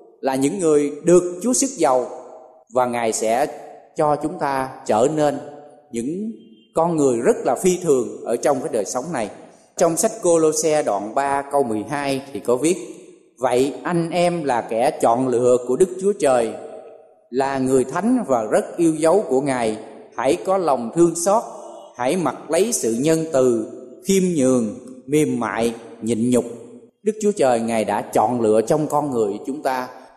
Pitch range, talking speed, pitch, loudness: 125-170 Hz, 175 wpm, 140 Hz, -20 LUFS